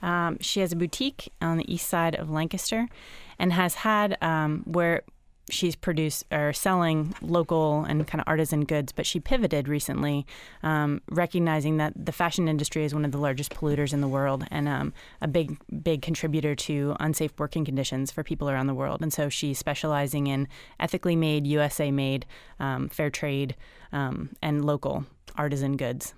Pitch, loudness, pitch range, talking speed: 155 Hz, -27 LUFS, 145-170 Hz, 175 wpm